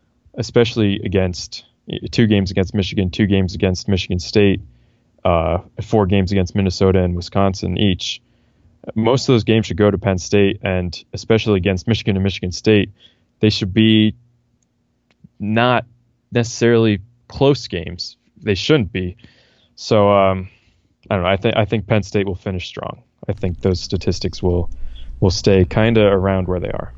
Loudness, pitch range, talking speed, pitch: -18 LUFS, 95-110 Hz, 160 wpm, 100 Hz